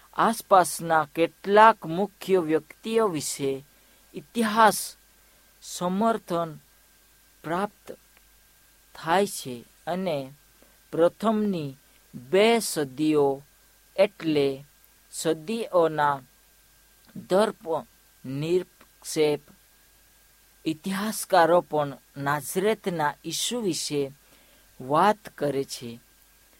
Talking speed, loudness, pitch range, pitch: 55 wpm, -25 LUFS, 145-200 Hz, 165 Hz